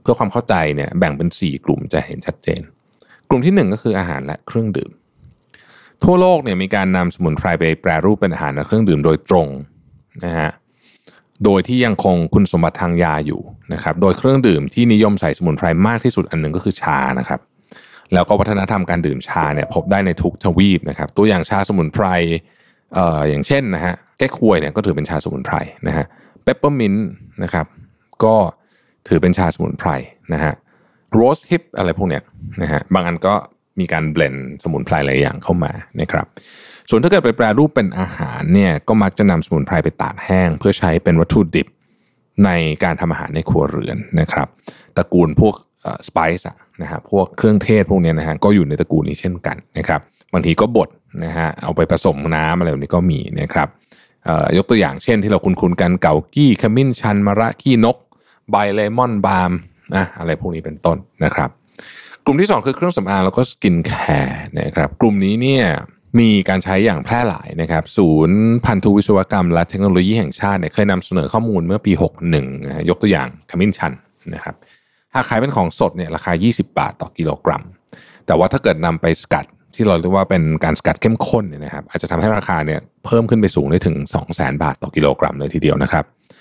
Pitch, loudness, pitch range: 95 Hz, -16 LUFS, 80-105 Hz